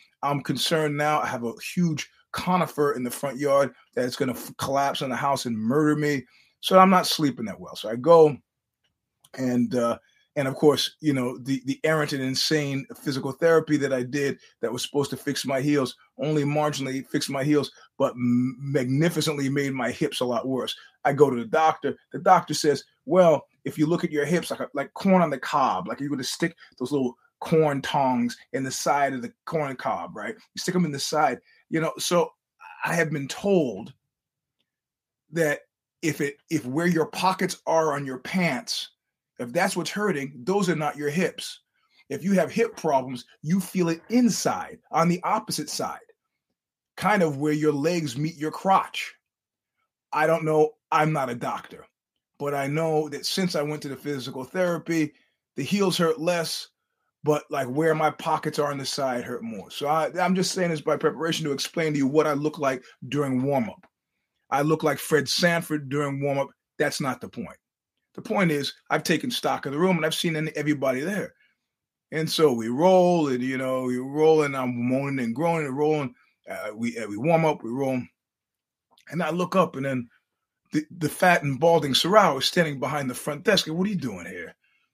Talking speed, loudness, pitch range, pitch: 205 wpm, -25 LUFS, 135-165 Hz, 150 Hz